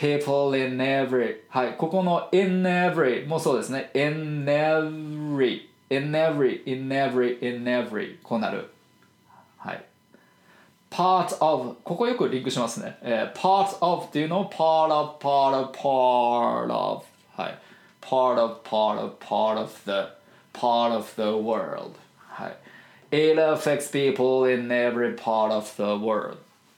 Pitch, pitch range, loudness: 135 Hz, 125-155 Hz, -24 LUFS